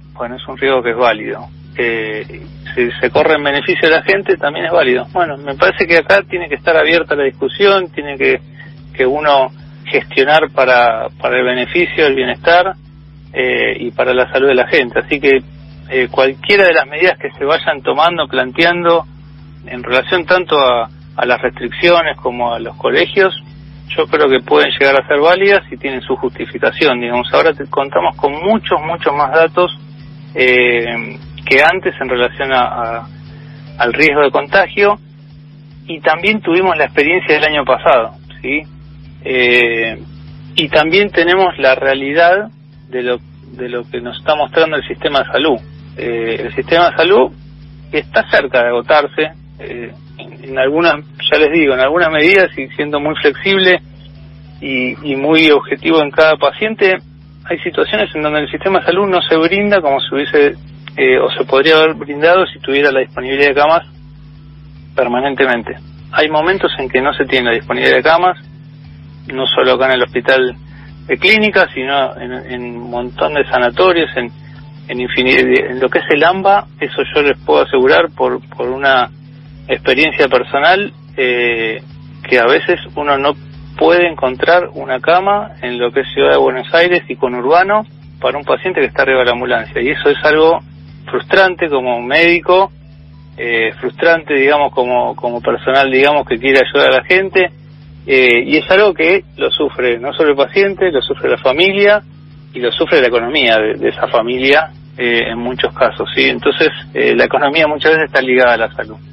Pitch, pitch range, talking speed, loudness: 145 Hz, 120-165 Hz, 180 wpm, -12 LUFS